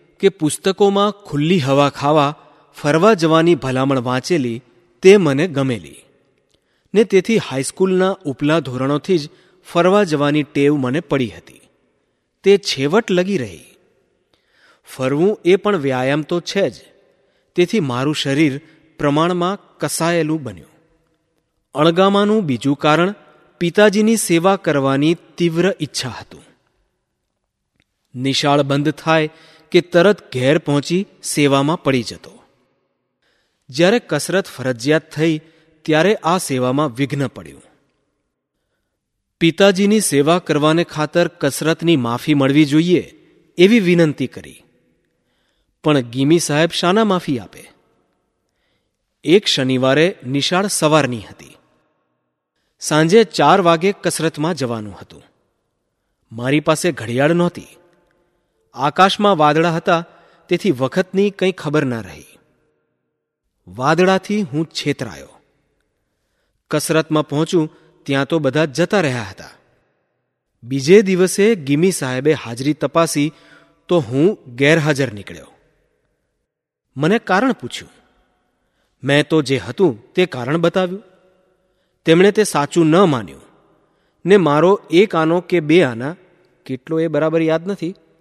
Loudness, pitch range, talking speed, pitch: -16 LUFS, 140-180 Hz, 105 wpm, 160 Hz